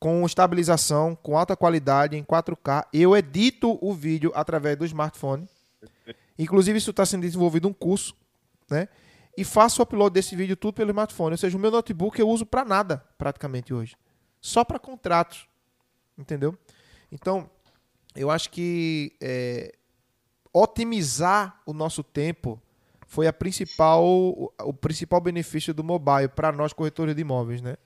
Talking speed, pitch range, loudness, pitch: 150 wpm, 140-190 Hz, -24 LUFS, 160 Hz